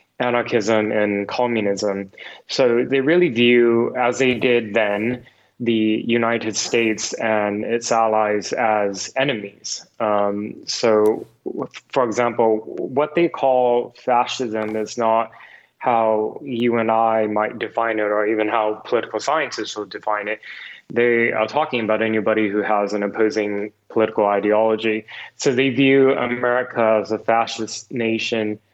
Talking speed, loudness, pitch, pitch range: 130 wpm, -20 LUFS, 110 Hz, 105-120 Hz